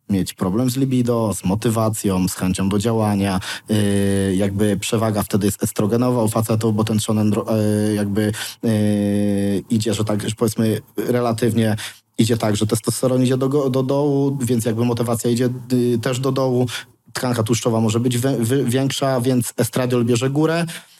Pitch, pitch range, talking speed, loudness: 115 Hz, 105-125 Hz, 155 wpm, -19 LUFS